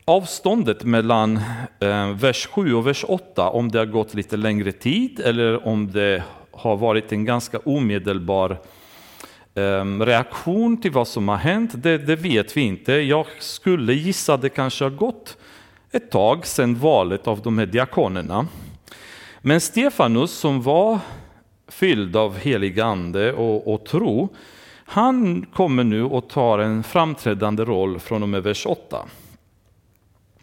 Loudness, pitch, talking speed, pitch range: -20 LUFS, 115 Hz, 145 wpm, 105-145 Hz